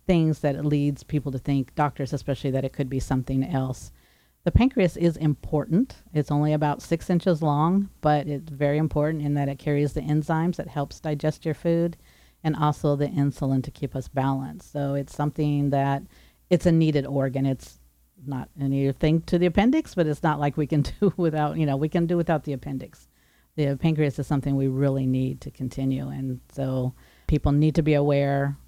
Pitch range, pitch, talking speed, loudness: 135-155 Hz, 145 Hz, 195 wpm, -25 LUFS